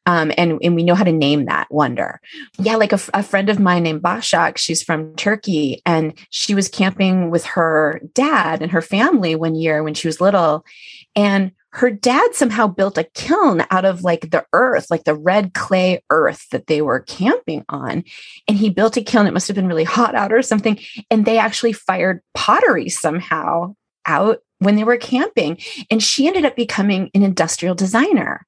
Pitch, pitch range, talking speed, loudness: 195 Hz, 170-225 Hz, 200 wpm, -17 LUFS